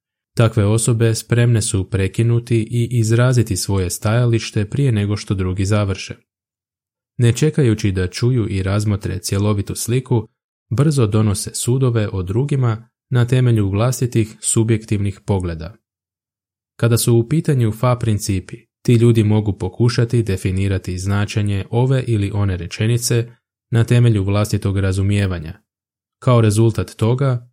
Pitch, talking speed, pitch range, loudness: 110 Hz, 120 wpm, 100-120 Hz, -18 LUFS